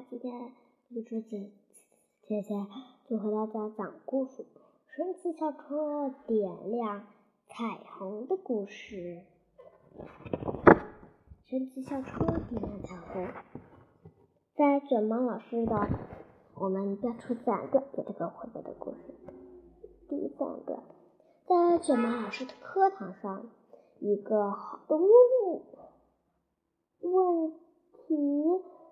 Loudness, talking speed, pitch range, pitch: -30 LUFS, 160 characters per minute, 210-310 Hz, 245 Hz